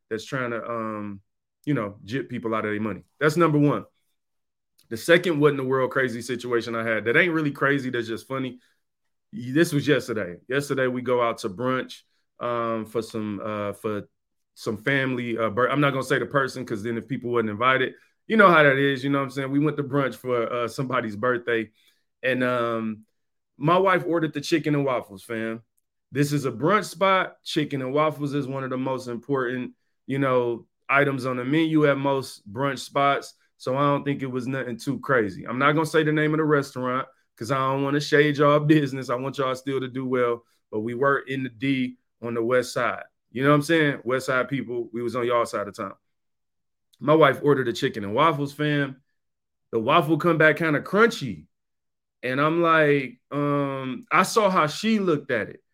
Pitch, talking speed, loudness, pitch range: 130 Hz, 215 wpm, -24 LUFS, 120-145 Hz